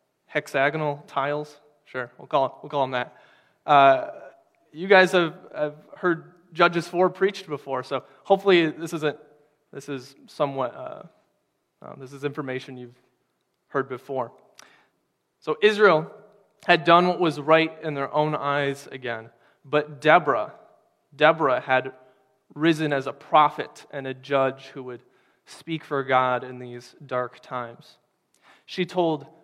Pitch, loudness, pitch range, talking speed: 145 Hz, -23 LUFS, 130-160 Hz, 140 wpm